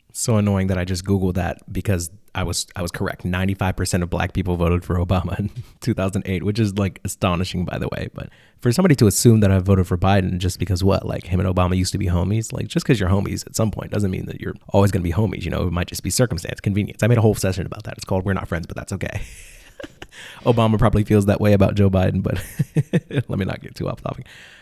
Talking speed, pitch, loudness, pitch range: 265 wpm, 100 Hz, -21 LUFS, 90-110 Hz